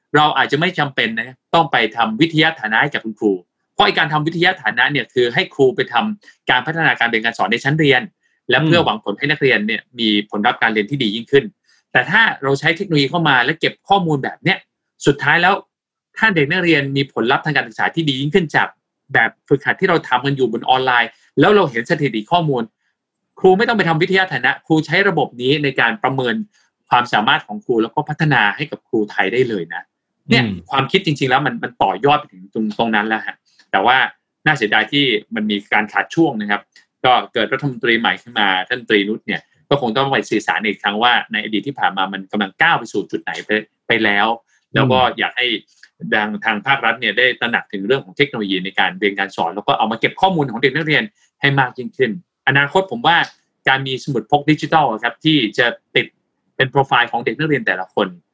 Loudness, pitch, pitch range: -16 LUFS, 135 Hz, 110-155 Hz